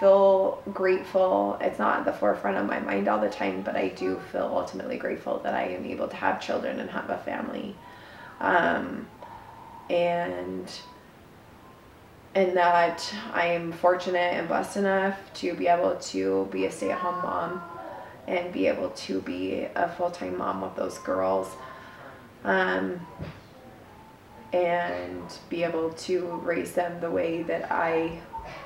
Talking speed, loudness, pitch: 145 wpm, -27 LUFS, 175 Hz